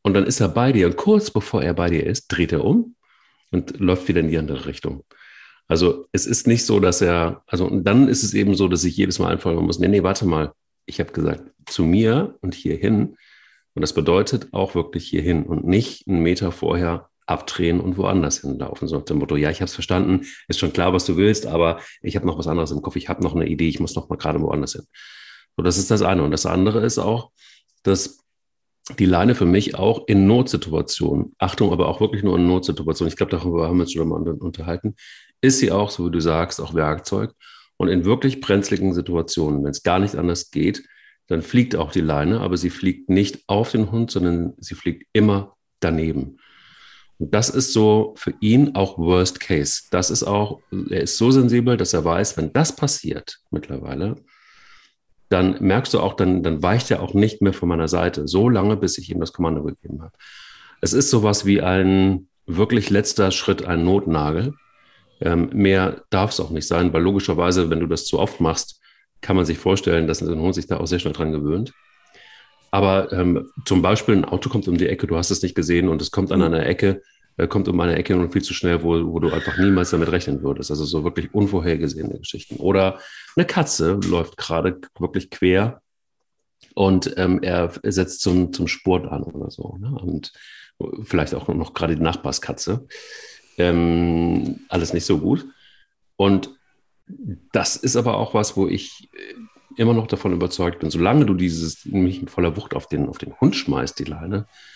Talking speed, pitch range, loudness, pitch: 205 wpm, 85-105 Hz, -20 LUFS, 95 Hz